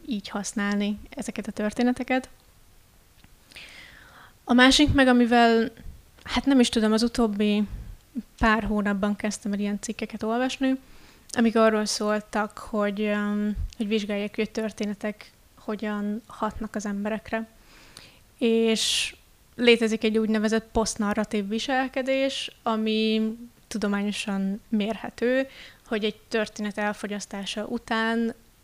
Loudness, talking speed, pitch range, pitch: -25 LUFS, 105 wpm, 210-235 Hz, 220 Hz